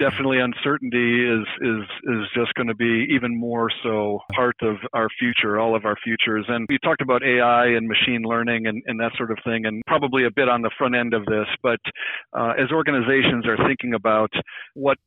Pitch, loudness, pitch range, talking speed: 120 Hz, -21 LUFS, 110-125 Hz, 205 wpm